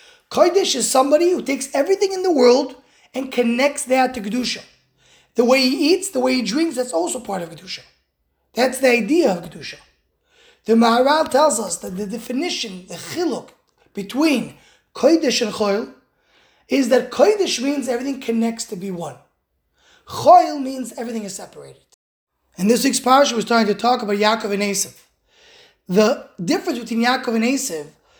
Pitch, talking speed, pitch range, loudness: 255 Hz, 165 wpm, 230-305 Hz, -18 LUFS